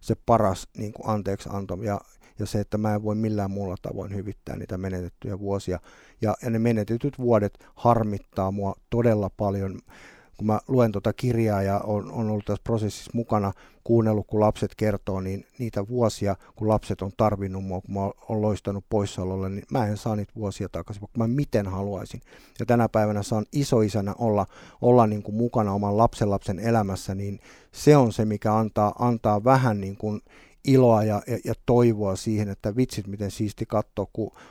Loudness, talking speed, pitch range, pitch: -25 LUFS, 180 wpm, 100-115 Hz, 105 Hz